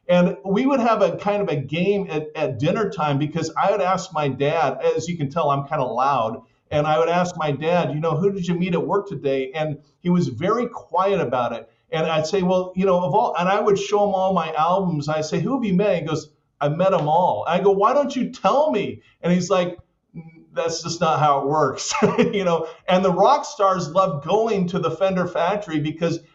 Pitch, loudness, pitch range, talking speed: 180 Hz, -21 LUFS, 155-195 Hz, 240 wpm